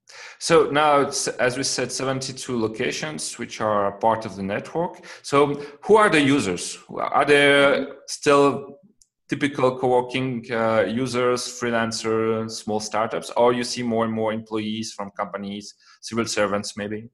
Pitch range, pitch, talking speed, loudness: 110-140 Hz, 120 Hz, 150 wpm, -22 LUFS